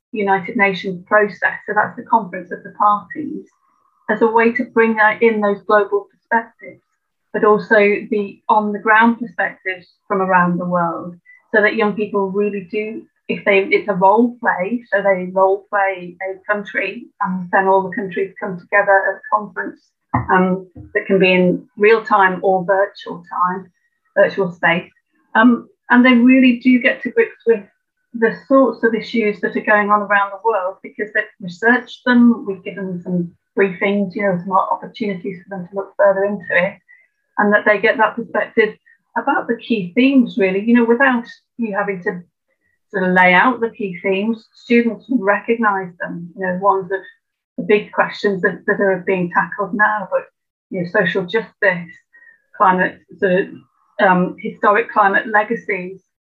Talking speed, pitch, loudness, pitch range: 175 wpm, 210 Hz, -16 LUFS, 195-230 Hz